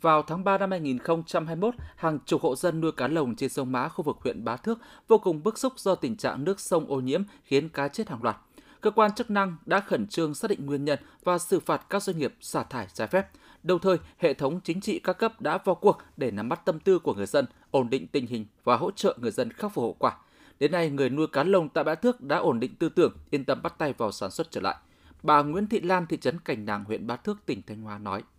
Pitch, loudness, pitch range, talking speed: 165 Hz, -27 LUFS, 140-195 Hz, 270 wpm